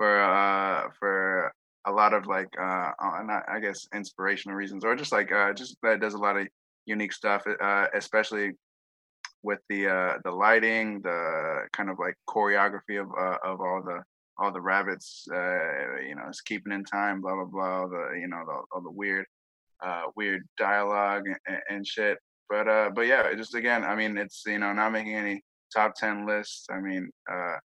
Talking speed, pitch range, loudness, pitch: 190 wpm, 95-105 Hz, -28 LUFS, 100 Hz